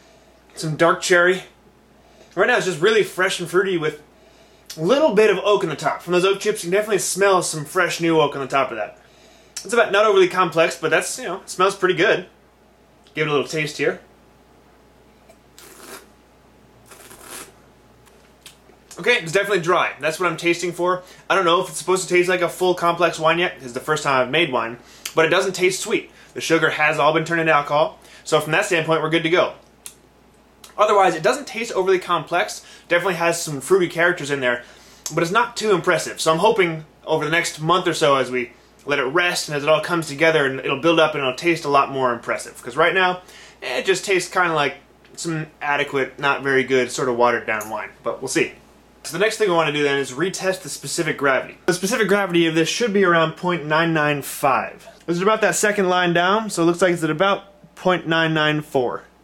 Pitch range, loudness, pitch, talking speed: 150-185 Hz, -19 LUFS, 170 Hz, 220 wpm